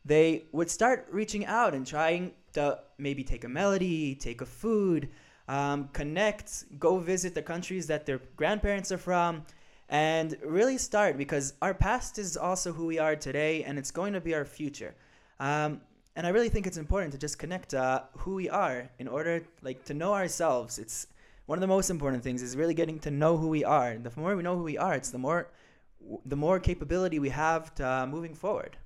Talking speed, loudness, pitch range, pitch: 210 wpm, -30 LUFS, 140-180 Hz, 155 Hz